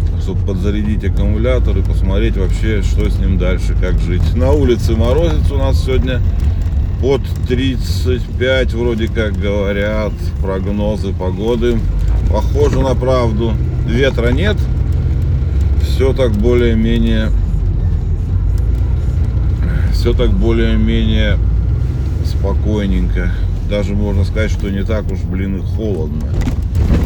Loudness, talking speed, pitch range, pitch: -15 LUFS, 105 wpm, 85-105 Hz, 95 Hz